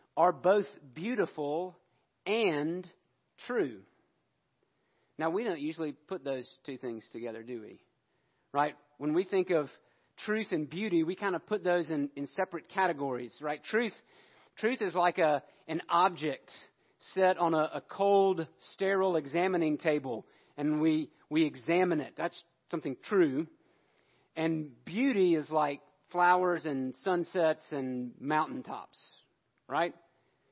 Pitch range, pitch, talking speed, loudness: 150-185 Hz, 160 Hz, 130 wpm, -32 LUFS